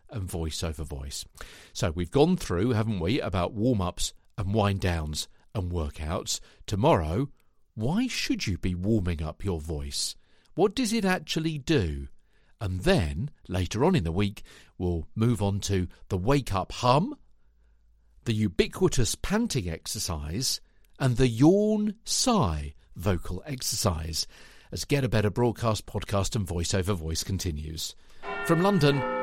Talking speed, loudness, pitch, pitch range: 145 wpm, -28 LUFS, 100 Hz, 85-130 Hz